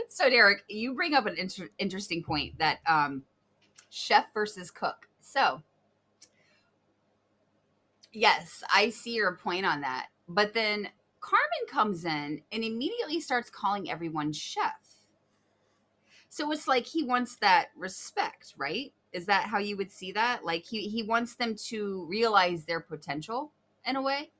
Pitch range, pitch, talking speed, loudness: 180-255 Hz, 210 Hz, 150 wpm, -29 LUFS